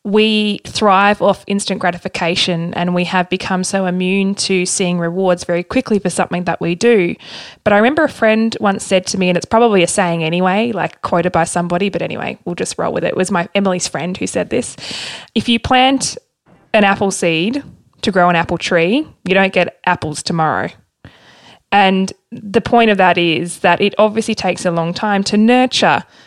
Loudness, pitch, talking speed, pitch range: -15 LUFS, 190 Hz, 195 wpm, 175-210 Hz